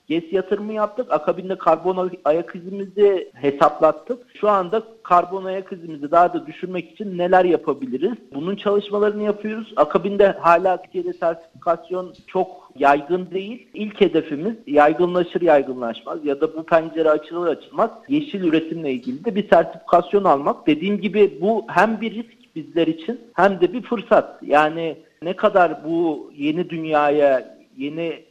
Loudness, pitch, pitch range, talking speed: -20 LUFS, 185 Hz, 160-210 Hz, 140 wpm